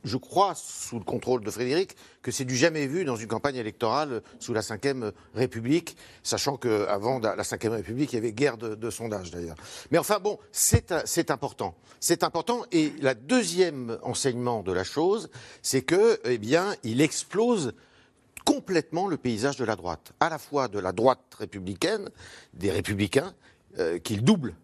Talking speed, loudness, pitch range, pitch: 180 wpm, -27 LUFS, 110-165 Hz, 125 Hz